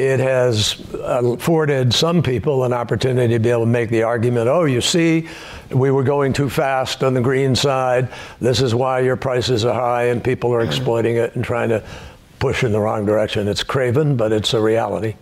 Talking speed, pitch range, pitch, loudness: 205 wpm, 115-135 Hz, 125 Hz, -18 LUFS